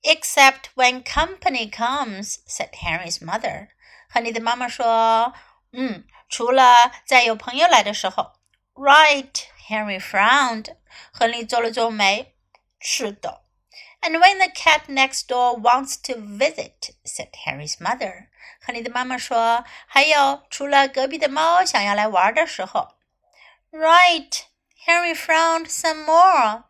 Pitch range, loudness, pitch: 235-320 Hz, -18 LUFS, 265 Hz